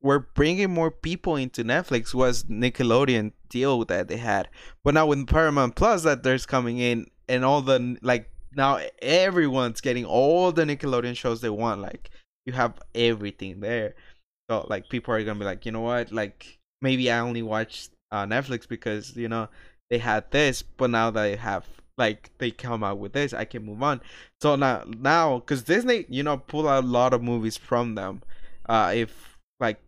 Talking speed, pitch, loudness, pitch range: 195 wpm, 120 Hz, -25 LUFS, 115-135 Hz